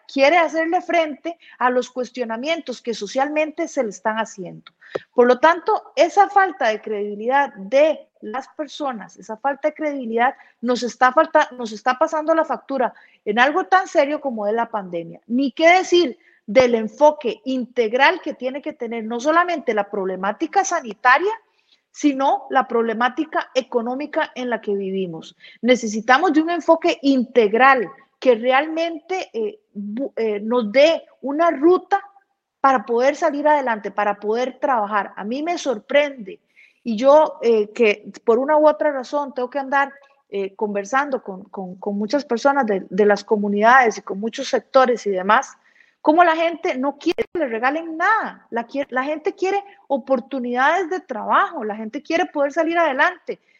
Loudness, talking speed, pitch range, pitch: -19 LUFS, 160 wpm, 230-320 Hz, 270 Hz